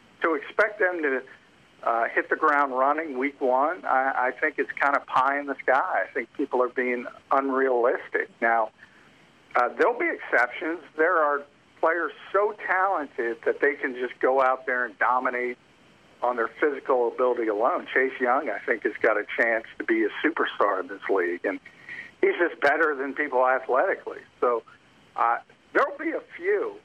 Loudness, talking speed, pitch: -25 LUFS, 175 wpm, 135 Hz